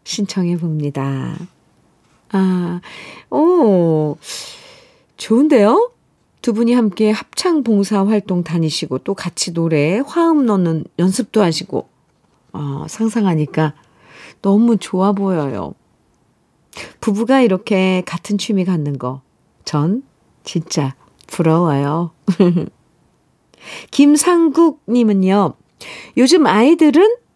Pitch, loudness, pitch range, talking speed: 195 Hz, -16 LUFS, 165-235 Hz, 190 characters per minute